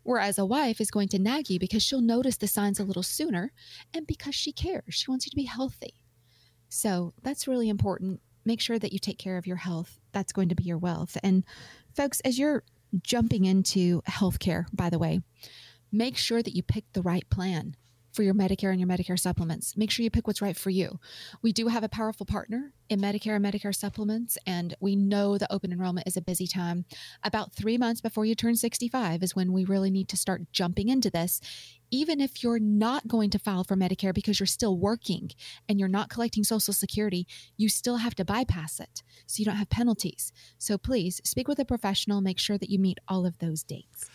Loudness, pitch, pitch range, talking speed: -28 LUFS, 200 Hz, 180-225 Hz, 220 wpm